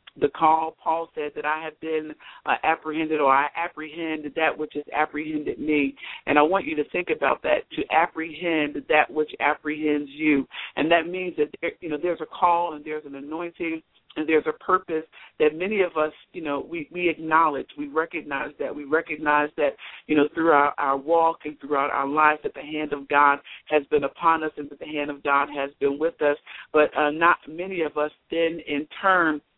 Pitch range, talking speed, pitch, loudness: 150-160 Hz, 205 wpm, 155 Hz, -24 LUFS